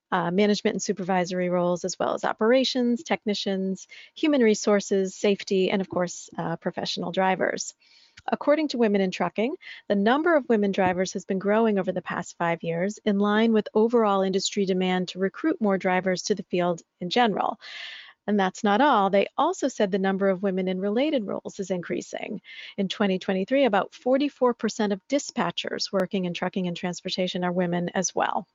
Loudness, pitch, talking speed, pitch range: -25 LUFS, 200 Hz, 175 wpm, 185-220 Hz